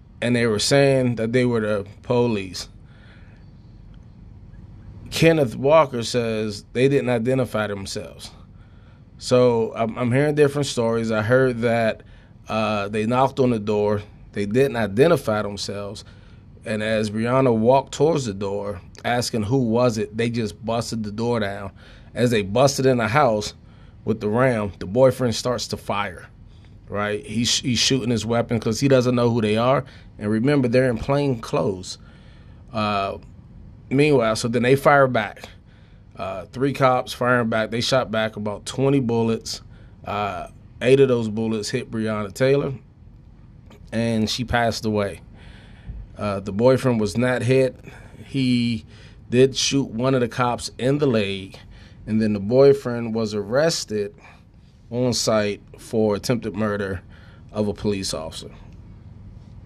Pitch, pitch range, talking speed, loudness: 110 Hz, 105-125 Hz, 145 wpm, -21 LUFS